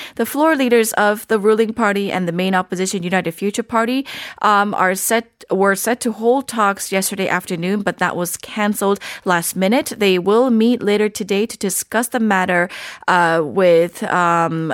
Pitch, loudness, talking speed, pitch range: 200 Hz, -17 LUFS, 170 wpm, 185-225 Hz